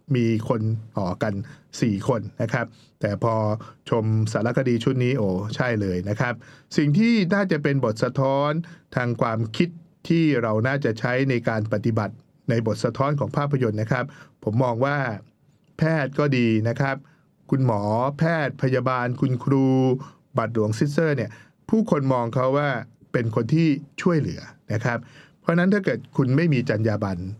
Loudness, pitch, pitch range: -23 LUFS, 130 Hz, 115-150 Hz